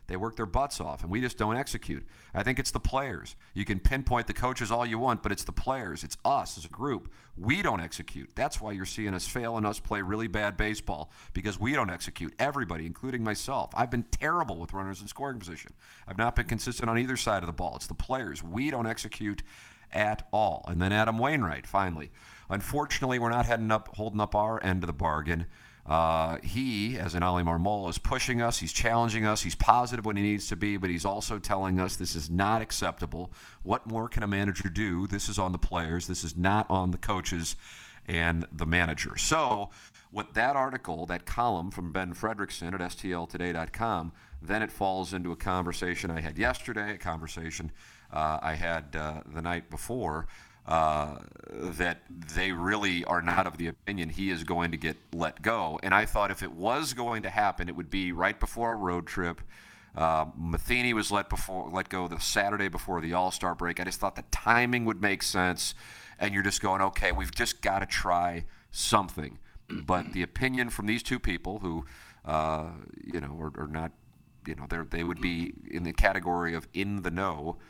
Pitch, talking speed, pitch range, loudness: 95 Hz, 205 wpm, 85-110 Hz, -31 LUFS